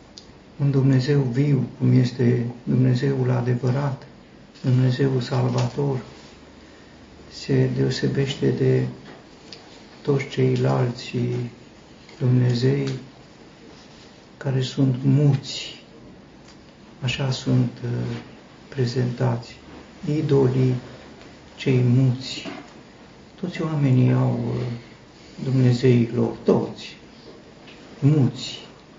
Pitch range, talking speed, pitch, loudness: 125-135 Hz, 65 wpm, 130 Hz, -22 LUFS